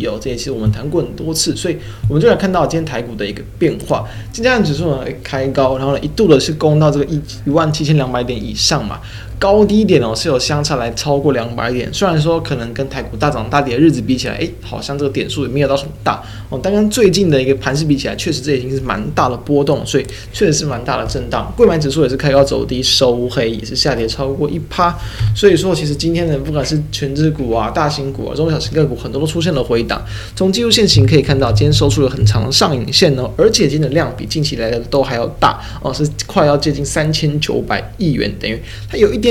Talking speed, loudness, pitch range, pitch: 370 characters per minute, -15 LUFS, 115-155 Hz, 140 Hz